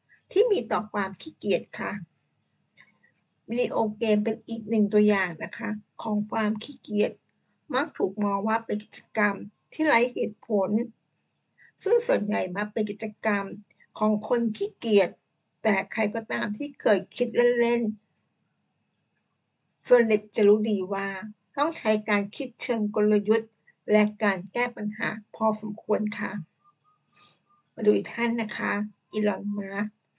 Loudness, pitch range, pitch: -26 LUFS, 205-230 Hz, 215 Hz